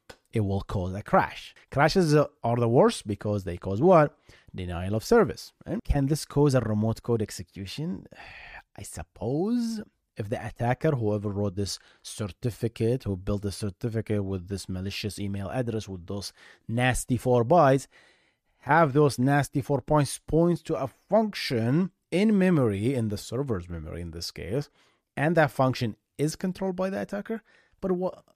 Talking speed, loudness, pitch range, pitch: 160 wpm, -27 LUFS, 100-150 Hz, 120 Hz